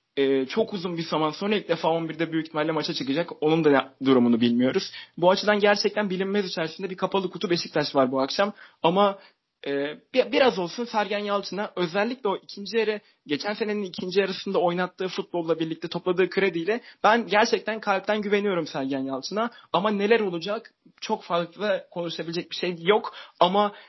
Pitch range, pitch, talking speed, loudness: 165-210 Hz, 190 Hz, 160 wpm, -25 LUFS